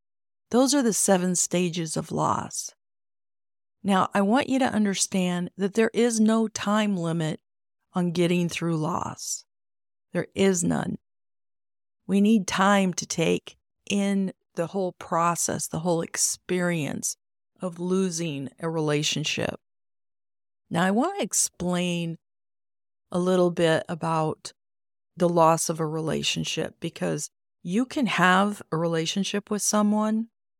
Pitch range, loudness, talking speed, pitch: 155-200 Hz, -25 LUFS, 125 wpm, 175 Hz